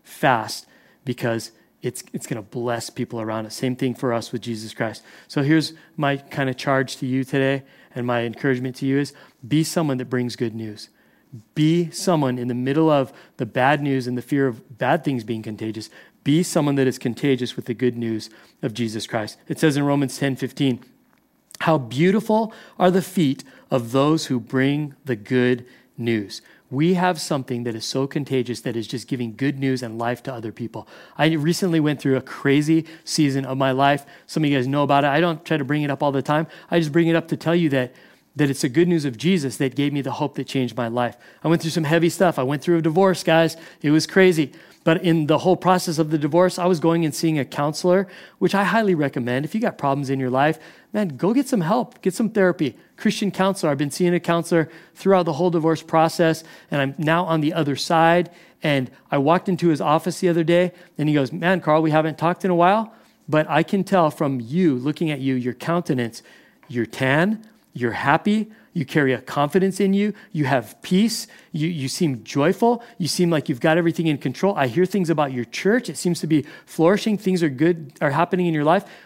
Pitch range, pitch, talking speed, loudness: 130-170 Hz, 150 Hz, 225 wpm, -21 LUFS